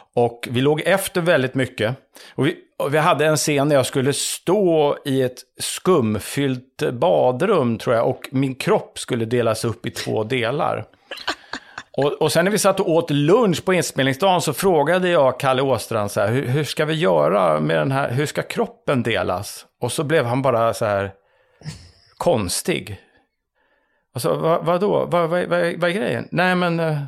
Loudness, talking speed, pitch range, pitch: -20 LUFS, 180 wpm, 125-170 Hz, 140 Hz